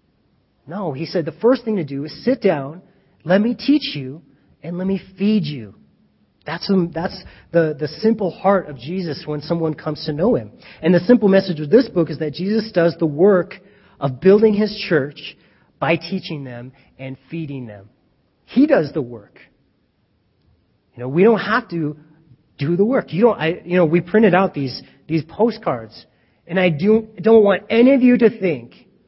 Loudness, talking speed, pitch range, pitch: -18 LUFS, 190 wpm, 150-205 Hz, 170 Hz